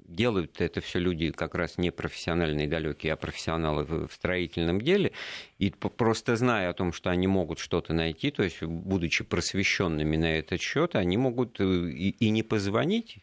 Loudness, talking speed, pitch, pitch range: -28 LUFS, 170 wpm, 90 Hz, 80-105 Hz